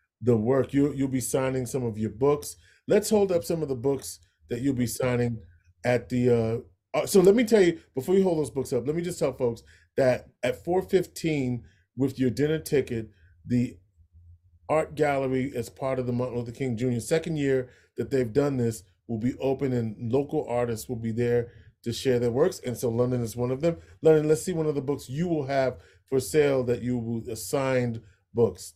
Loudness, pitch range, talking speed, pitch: -27 LUFS, 115-145 Hz, 210 wpm, 125 Hz